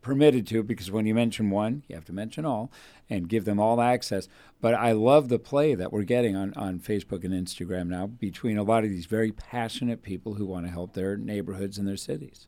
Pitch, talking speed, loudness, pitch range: 105 Hz, 230 wpm, -27 LUFS, 95-115 Hz